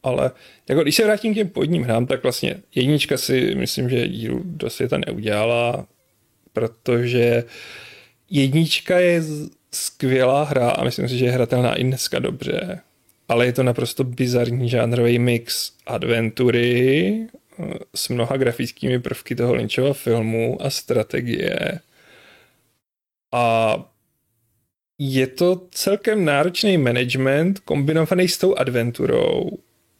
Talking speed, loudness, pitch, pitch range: 120 wpm, -20 LUFS, 130 Hz, 120-165 Hz